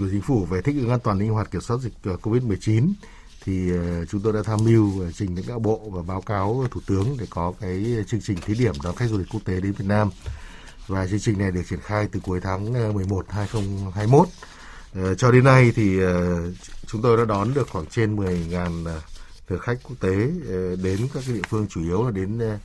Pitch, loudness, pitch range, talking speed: 100 Hz, -23 LUFS, 90-115 Hz, 215 wpm